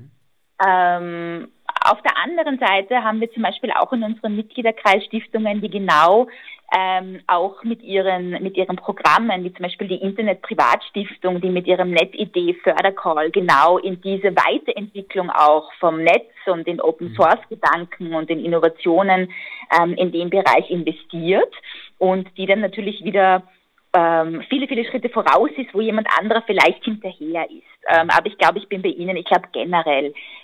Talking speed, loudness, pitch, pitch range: 155 wpm, -18 LUFS, 185 Hz, 170-210 Hz